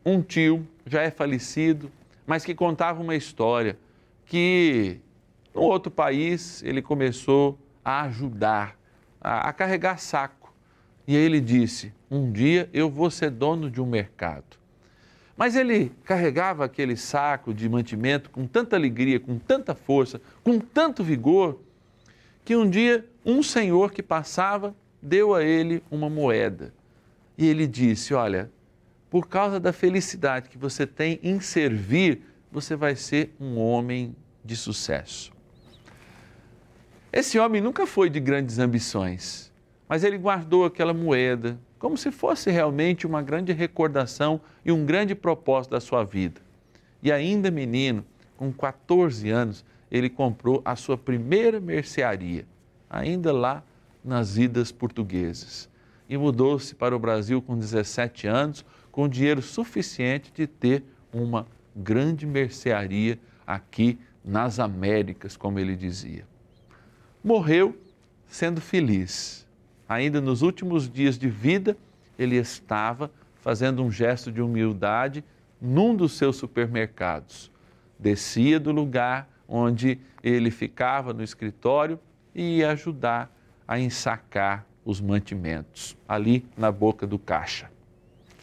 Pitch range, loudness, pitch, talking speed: 115-160 Hz, -25 LUFS, 135 Hz, 125 wpm